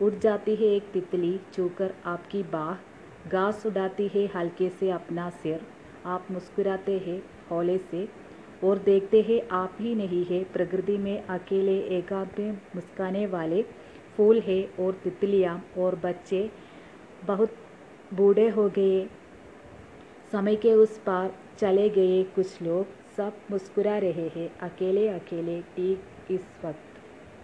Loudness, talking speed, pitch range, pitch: -27 LUFS, 135 wpm, 180-205 Hz, 190 Hz